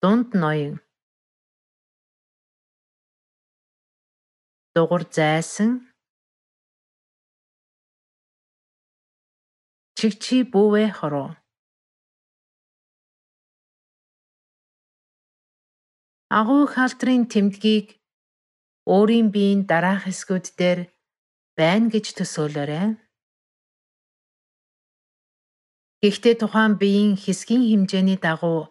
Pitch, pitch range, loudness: 200 Hz, 175-220 Hz, -20 LUFS